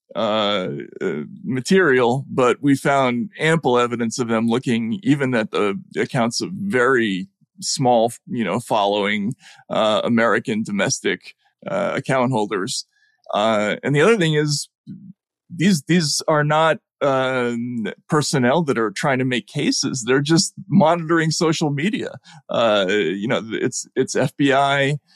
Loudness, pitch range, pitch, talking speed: -19 LUFS, 125-170 Hz, 140 Hz, 135 wpm